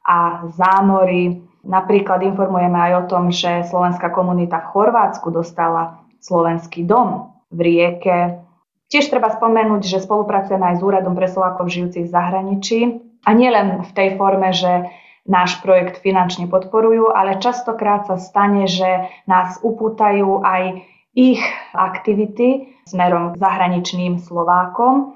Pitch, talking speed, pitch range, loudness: 185 Hz, 130 wpm, 180-210 Hz, -16 LUFS